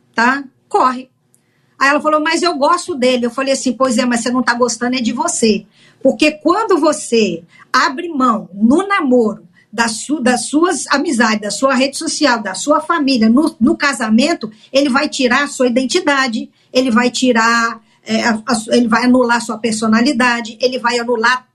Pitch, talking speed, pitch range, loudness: 255 Hz, 165 wpm, 235-285 Hz, -14 LUFS